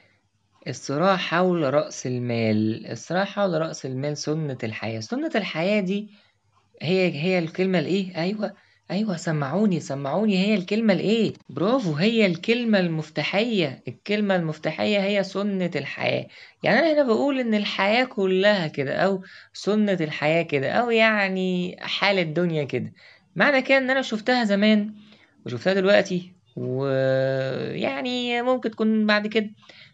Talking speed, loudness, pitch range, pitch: 130 wpm, -23 LUFS, 150-210 Hz, 190 Hz